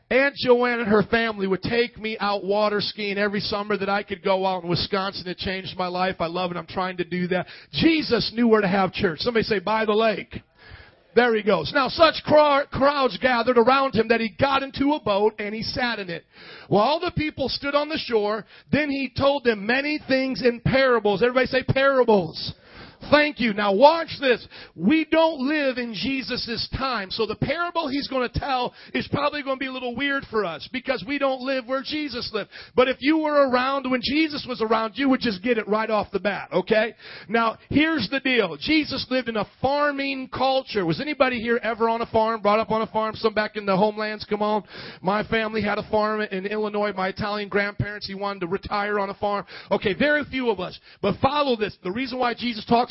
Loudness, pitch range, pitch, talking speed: -23 LUFS, 205-265 Hz, 230 Hz, 220 wpm